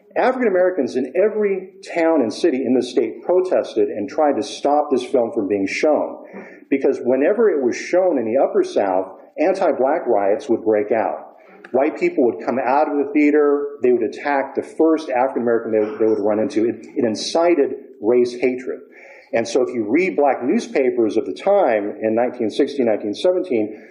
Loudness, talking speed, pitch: -19 LUFS, 180 wpm, 170 Hz